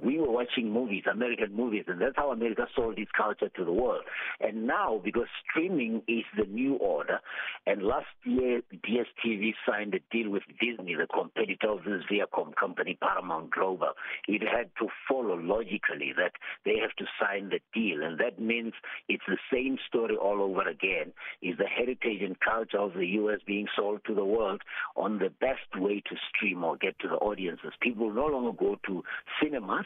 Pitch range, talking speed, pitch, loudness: 105-125 Hz, 185 wpm, 115 Hz, -31 LUFS